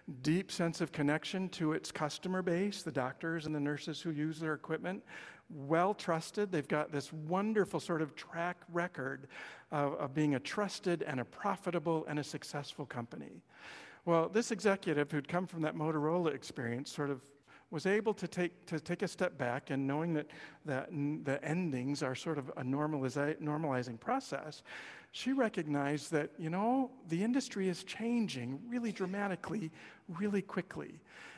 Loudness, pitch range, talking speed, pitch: -37 LUFS, 145-185 Hz, 165 wpm, 160 Hz